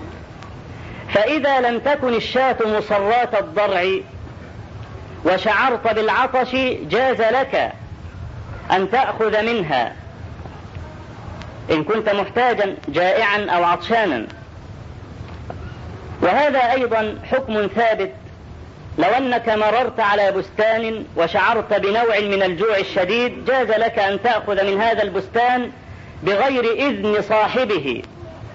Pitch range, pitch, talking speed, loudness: 185-240 Hz, 215 Hz, 90 wpm, -18 LUFS